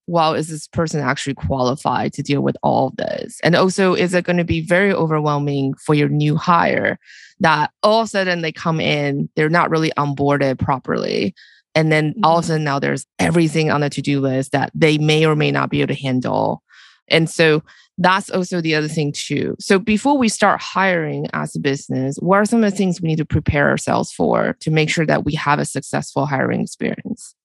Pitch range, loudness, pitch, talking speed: 145-175 Hz, -18 LUFS, 155 Hz, 220 wpm